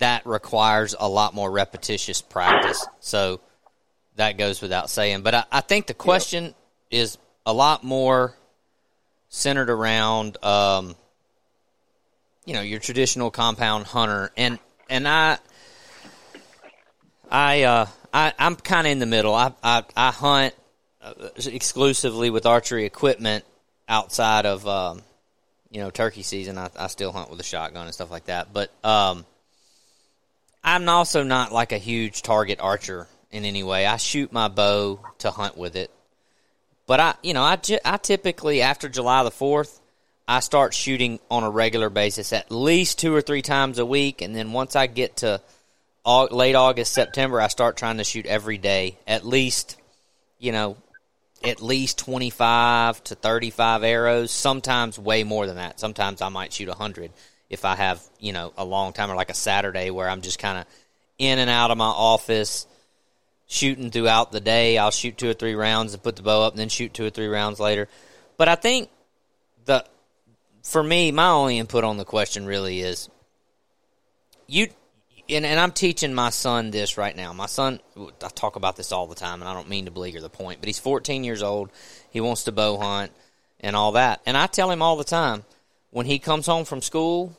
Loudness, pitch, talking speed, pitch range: -22 LUFS, 115 Hz, 185 wpm, 100-130 Hz